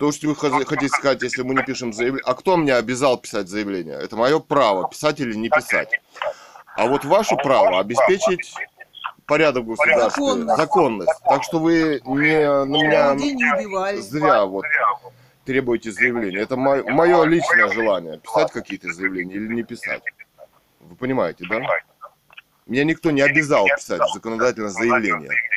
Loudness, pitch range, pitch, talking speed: -19 LUFS, 120-160 Hz, 140 Hz, 145 wpm